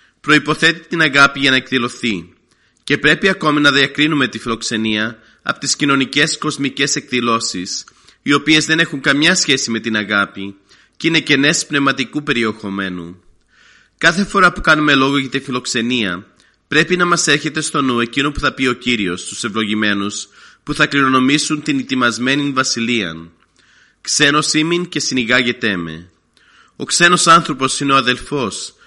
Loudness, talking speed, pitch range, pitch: -15 LUFS, 150 wpm, 115-150 Hz, 135 Hz